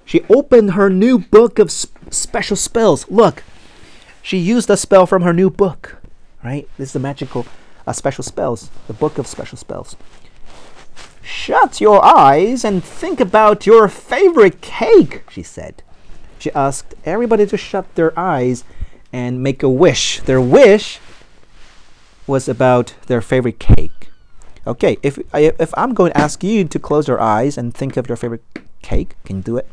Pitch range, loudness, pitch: 125-205 Hz, -13 LUFS, 150 Hz